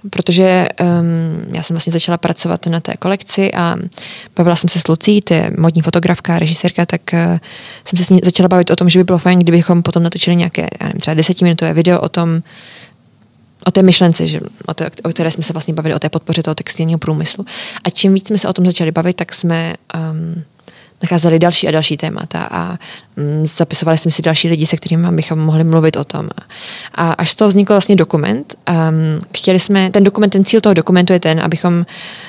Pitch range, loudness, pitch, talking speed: 165-185 Hz, -13 LUFS, 170 Hz, 210 wpm